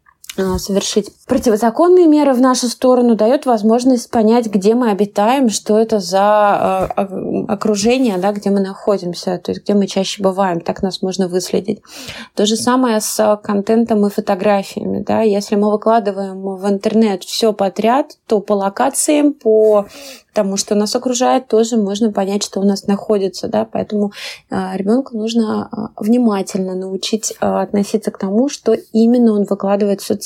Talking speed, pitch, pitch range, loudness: 150 wpm, 215 Hz, 200-230 Hz, -15 LUFS